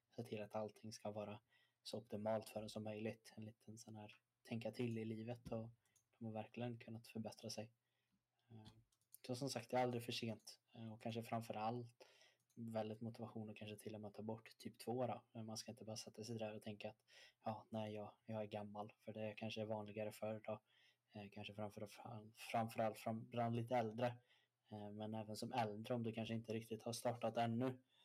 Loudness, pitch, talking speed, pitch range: -49 LUFS, 110 Hz, 200 wpm, 110-115 Hz